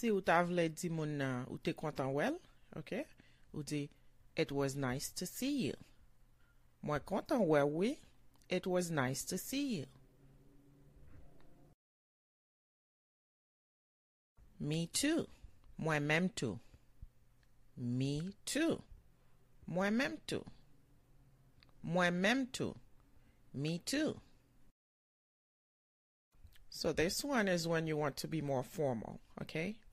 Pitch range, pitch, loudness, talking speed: 130-180 Hz, 150 Hz, -38 LUFS, 100 wpm